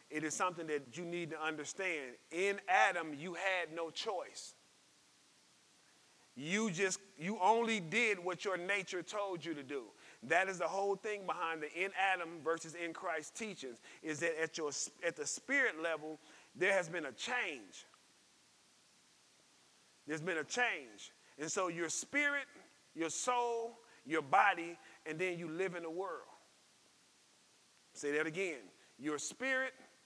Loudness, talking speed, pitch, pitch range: -38 LUFS, 150 wpm, 175 Hz, 160-200 Hz